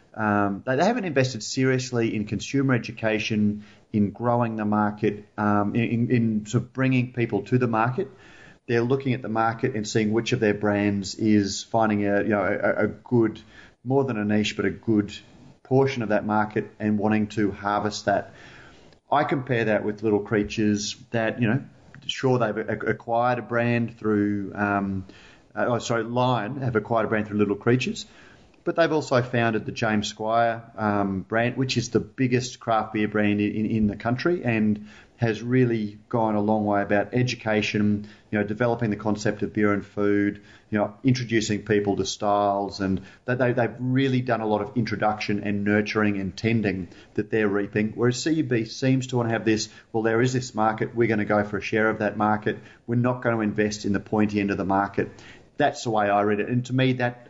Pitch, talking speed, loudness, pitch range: 110 Hz, 200 wpm, -24 LUFS, 105-120 Hz